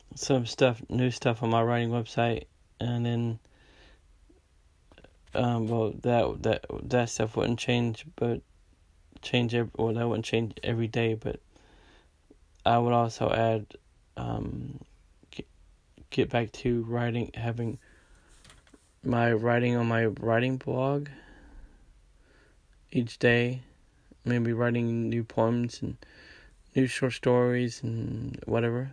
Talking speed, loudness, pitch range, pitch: 115 wpm, -29 LUFS, 115-125 Hz, 120 Hz